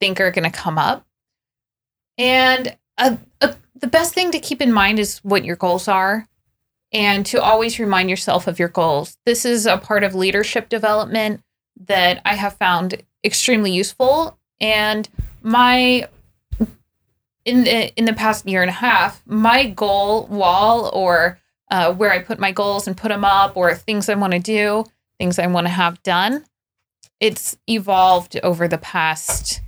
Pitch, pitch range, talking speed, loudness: 205 Hz, 180-225 Hz, 170 wpm, -17 LUFS